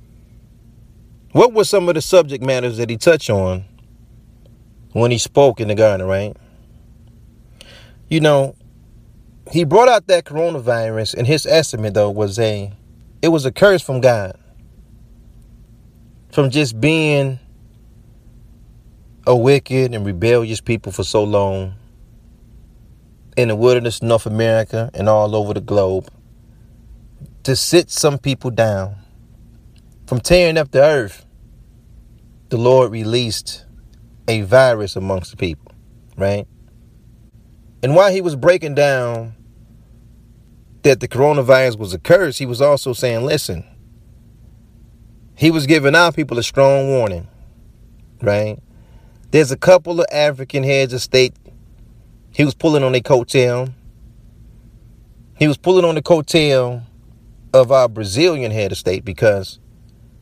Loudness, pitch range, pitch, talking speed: -15 LUFS, 115-135 Hz, 115 Hz, 130 wpm